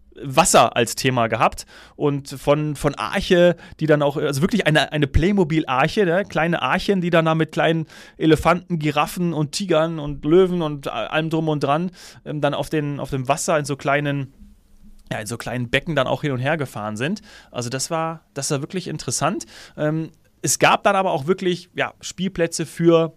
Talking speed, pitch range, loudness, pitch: 185 wpm, 140-170 Hz, -20 LUFS, 155 Hz